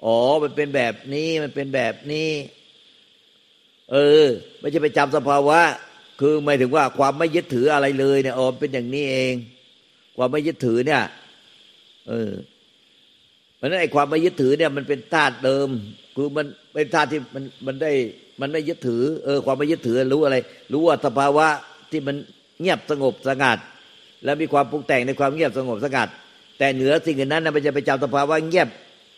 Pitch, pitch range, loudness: 145 Hz, 135-155 Hz, -21 LUFS